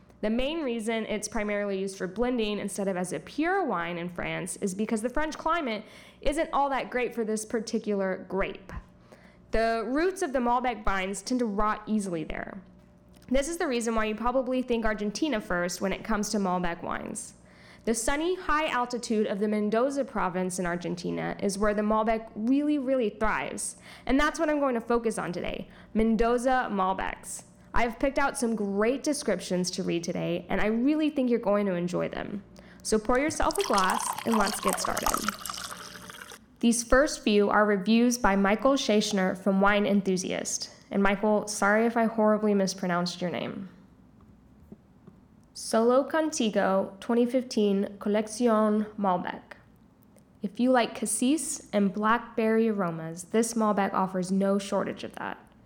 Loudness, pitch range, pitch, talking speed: -28 LUFS, 195-245 Hz, 215 Hz, 160 wpm